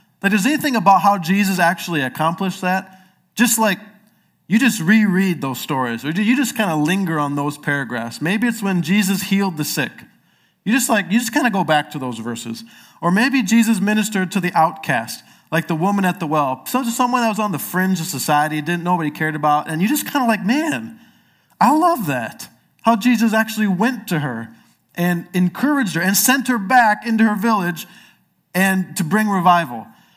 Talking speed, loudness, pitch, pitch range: 205 wpm, -18 LUFS, 190 Hz, 165-225 Hz